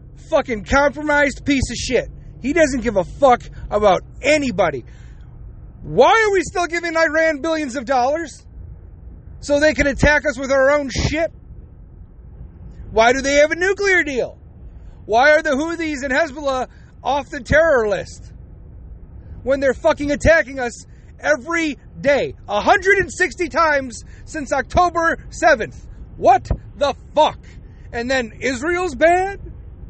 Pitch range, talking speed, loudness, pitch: 275-330 Hz, 130 wpm, -18 LUFS, 295 Hz